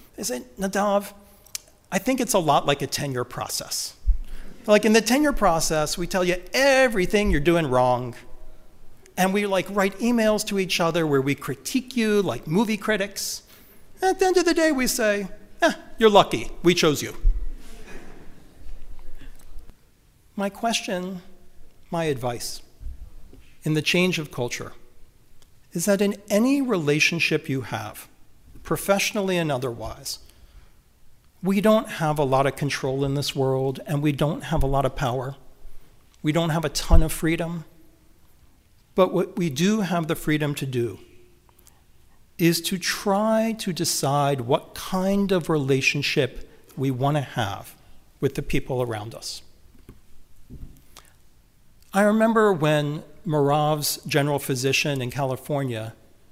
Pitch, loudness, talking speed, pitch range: 160 Hz, -23 LUFS, 140 wpm, 135-200 Hz